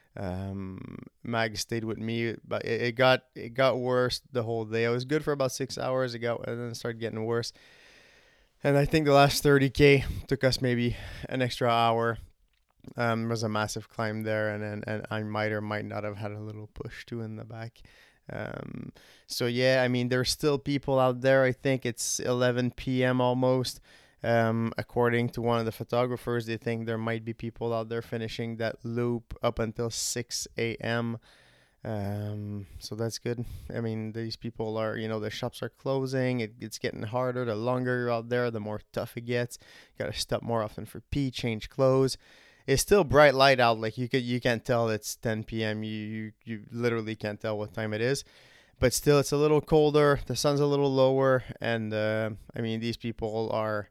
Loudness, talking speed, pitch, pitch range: -28 LUFS, 200 wpm, 115 Hz, 110-125 Hz